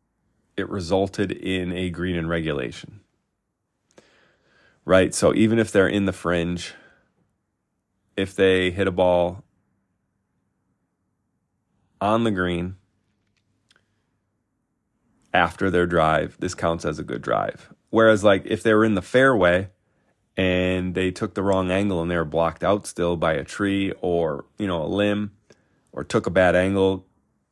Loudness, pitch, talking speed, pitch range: -22 LUFS, 95 Hz, 140 wpm, 90-100 Hz